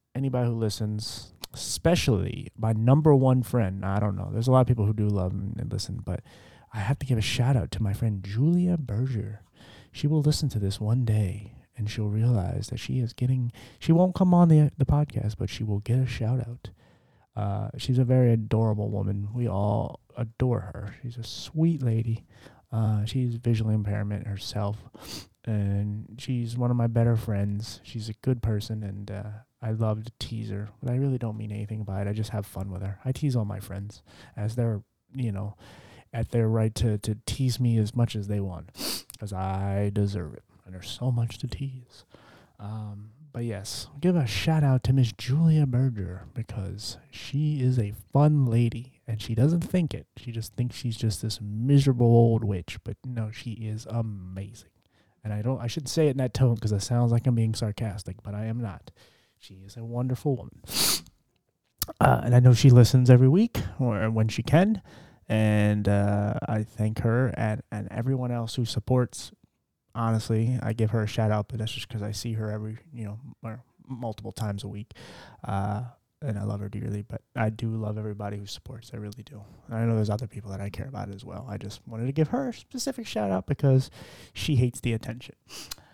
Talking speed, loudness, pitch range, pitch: 205 wpm, -27 LUFS, 105-125 Hz, 115 Hz